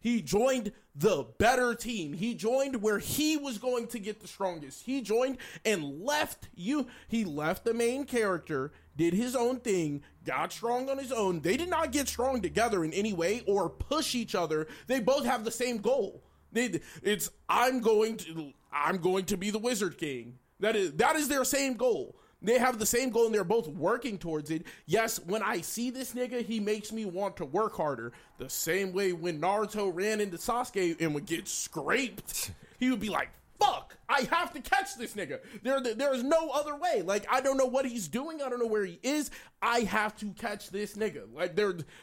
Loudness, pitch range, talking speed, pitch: -31 LUFS, 195-255 Hz, 205 wpm, 225 Hz